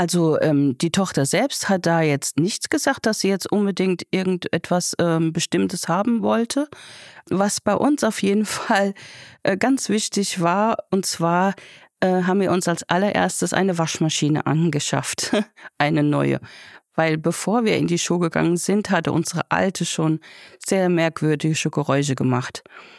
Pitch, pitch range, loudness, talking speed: 175 Hz, 160-200 Hz, -21 LUFS, 150 wpm